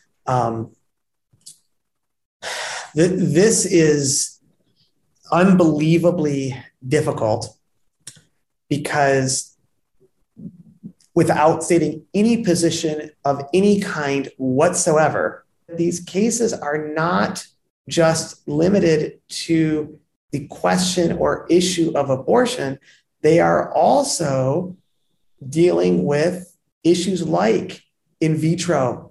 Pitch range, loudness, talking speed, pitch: 145-175 Hz, -19 LUFS, 75 wpm, 160 Hz